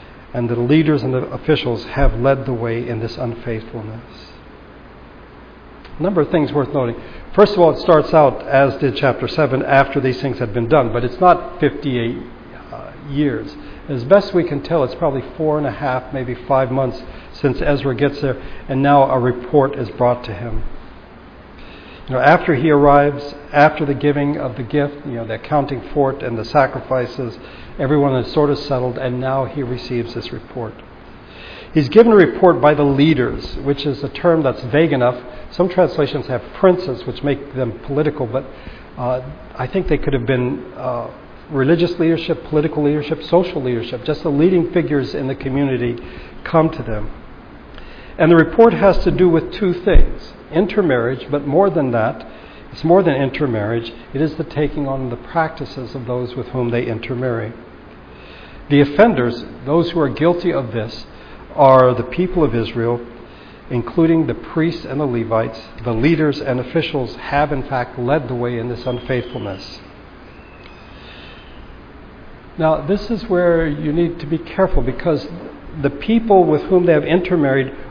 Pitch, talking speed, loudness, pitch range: 135 Hz, 170 wpm, -17 LUFS, 120-155 Hz